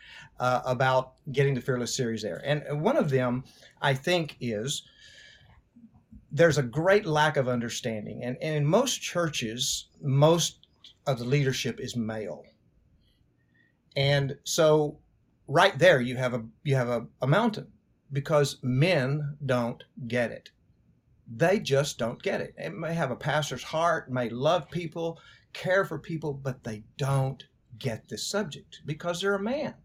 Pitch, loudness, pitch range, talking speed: 140 Hz, -27 LUFS, 125-160 Hz, 150 wpm